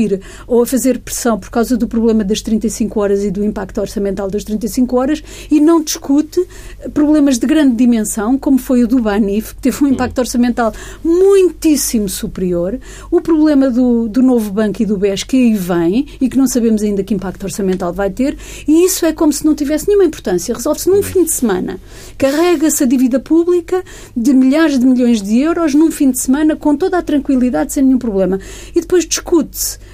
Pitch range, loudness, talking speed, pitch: 220-305 Hz, -14 LUFS, 195 wpm, 255 Hz